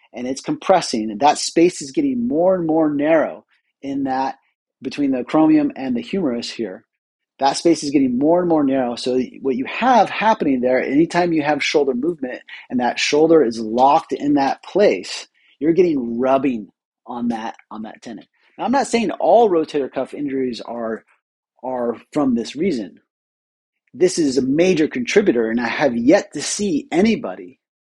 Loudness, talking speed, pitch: -18 LUFS, 175 wpm, 150 Hz